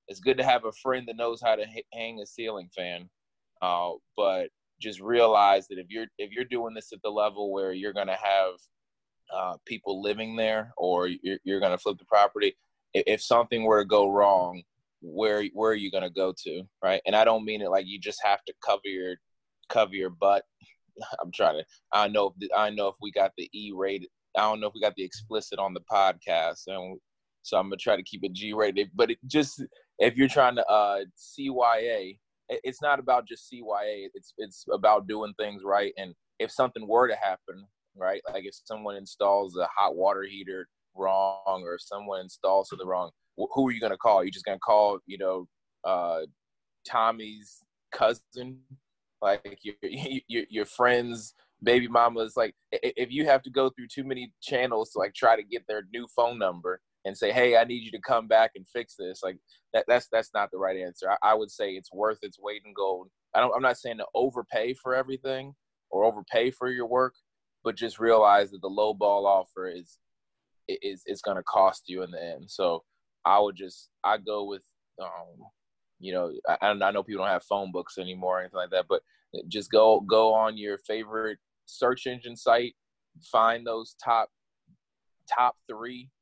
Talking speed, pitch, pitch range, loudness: 205 wpm, 105 Hz, 95-120 Hz, -27 LUFS